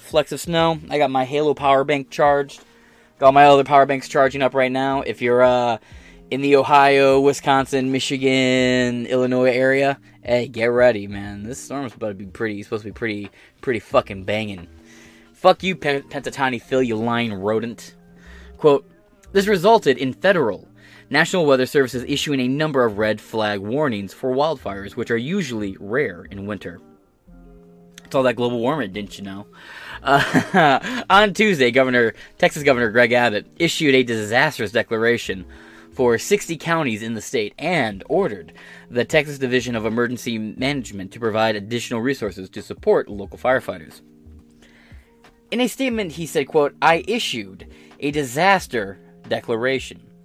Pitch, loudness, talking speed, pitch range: 125 Hz, -19 LUFS, 155 wpm, 105-140 Hz